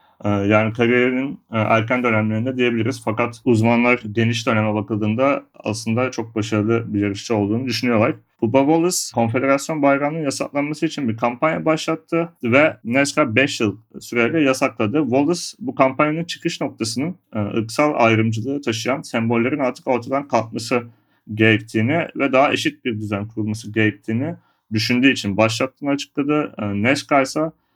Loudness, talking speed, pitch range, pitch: -19 LUFS, 125 wpm, 110-140 Hz, 120 Hz